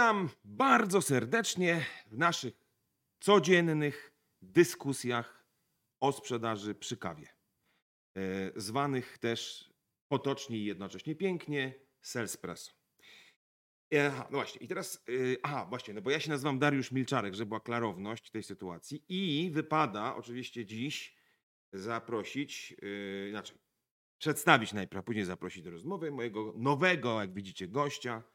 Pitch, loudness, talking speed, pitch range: 130 Hz, -33 LUFS, 120 wpm, 110-145 Hz